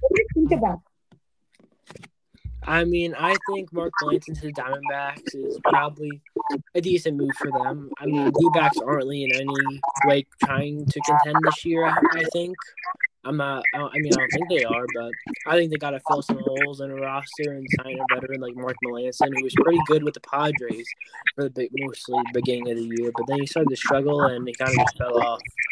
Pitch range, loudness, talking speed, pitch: 130-160 Hz, -23 LUFS, 210 wpm, 140 Hz